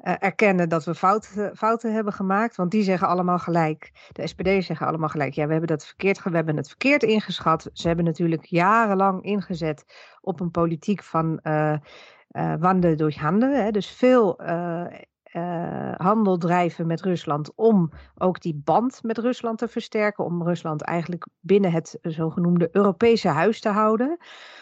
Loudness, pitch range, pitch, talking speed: -23 LUFS, 165-210 Hz, 180 Hz, 165 wpm